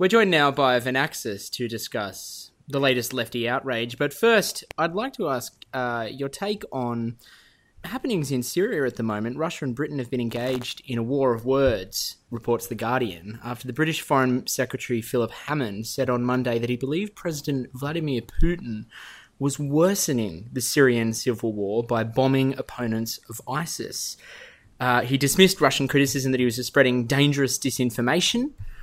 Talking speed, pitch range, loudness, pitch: 165 wpm, 120-140 Hz, -24 LUFS, 130 Hz